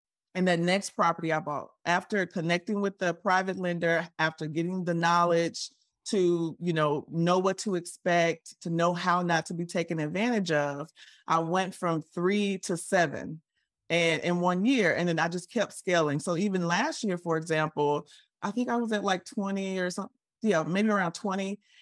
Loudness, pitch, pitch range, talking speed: -28 LUFS, 175 Hz, 165-195 Hz, 185 wpm